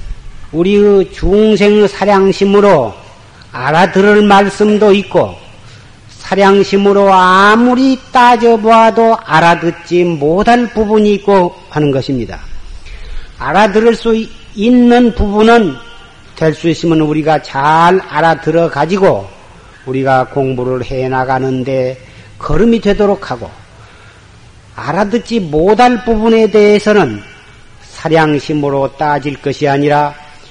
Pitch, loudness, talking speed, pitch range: 165 Hz, -10 LUFS, 230 characters per minute, 130-205 Hz